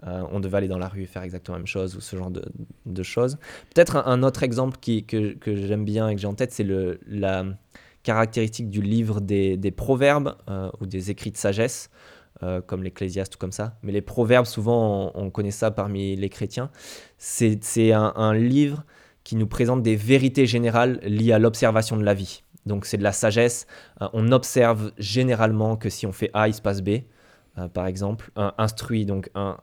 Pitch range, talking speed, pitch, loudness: 95-115 Hz, 220 wpm, 105 Hz, -23 LUFS